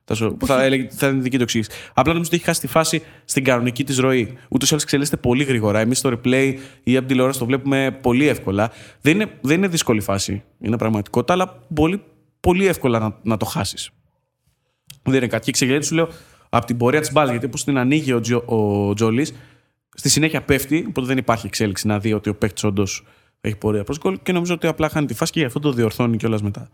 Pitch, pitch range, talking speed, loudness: 130 Hz, 110-150 Hz, 215 wpm, -19 LUFS